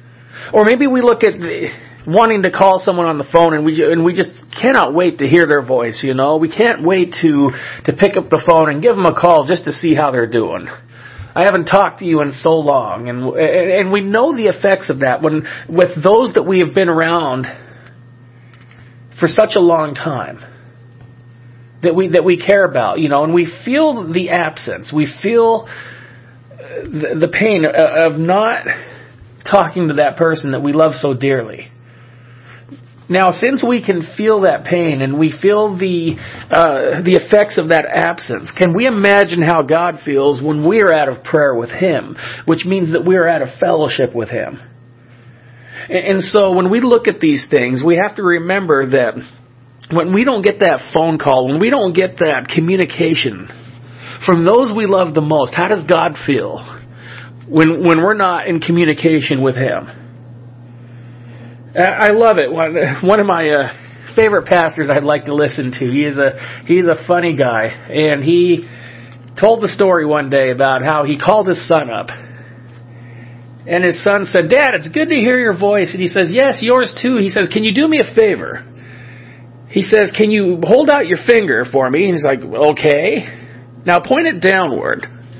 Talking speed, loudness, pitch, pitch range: 185 wpm, -13 LUFS, 160 Hz, 125-190 Hz